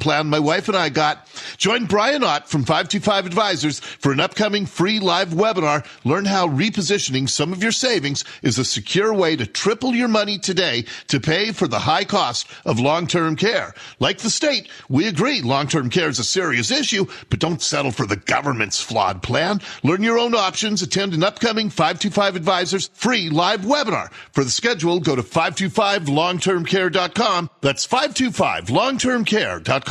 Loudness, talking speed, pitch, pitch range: -19 LUFS, 170 wpm, 190 Hz, 155-210 Hz